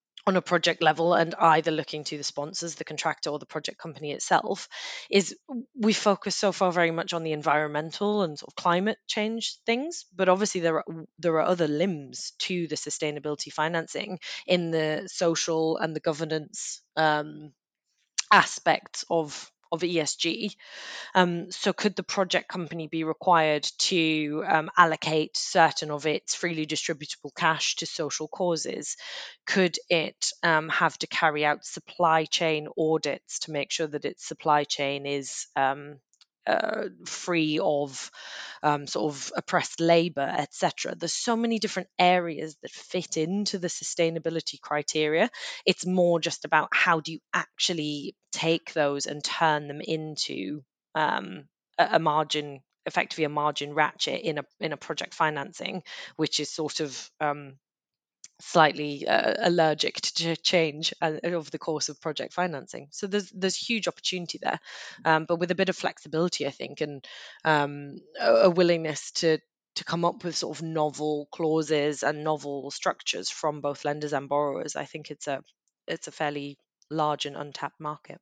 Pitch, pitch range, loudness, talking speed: 160 Hz, 150-175 Hz, -27 LUFS, 160 wpm